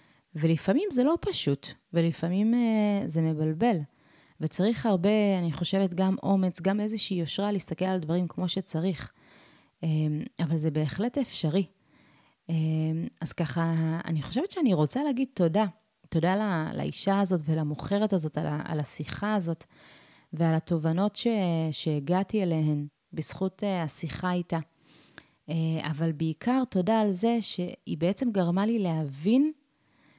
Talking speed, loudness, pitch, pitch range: 125 wpm, -28 LUFS, 175 Hz, 160-205 Hz